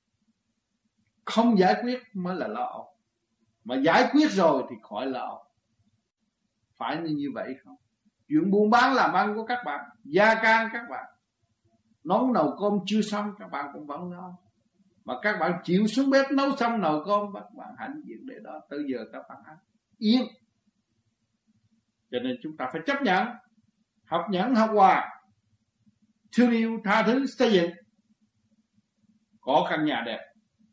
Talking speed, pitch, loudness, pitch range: 160 wpm, 205 Hz, -25 LUFS, 145-225 Hz